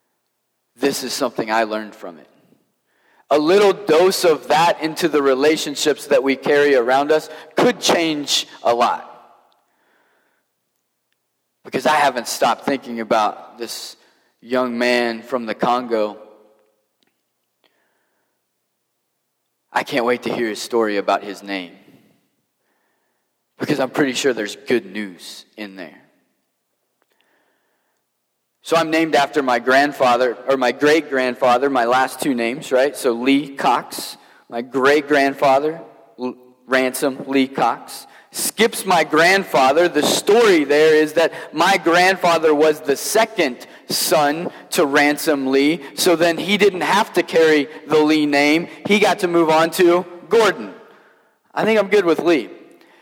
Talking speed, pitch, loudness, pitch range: 135 wpm, 140 Hz, -17 LUFS, 120-165 Hz